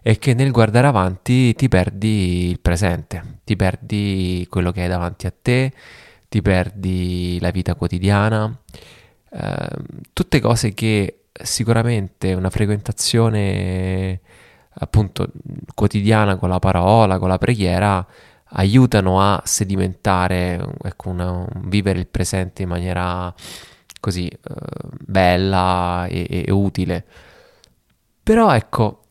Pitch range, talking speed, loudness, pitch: 90-115 Hz, 115 wpm, -18 LUFS, 100 Hz